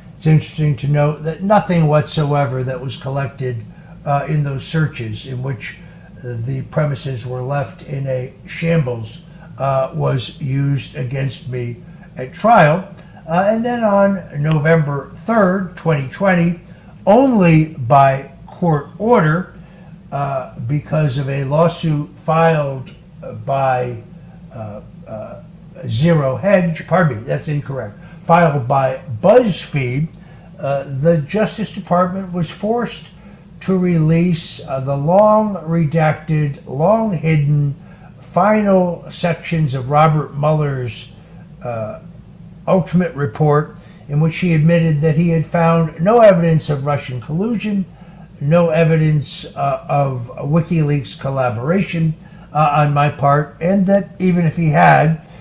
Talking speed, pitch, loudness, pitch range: 120 wpm, 160 Hz, -16 LUFS, 140-175 Hz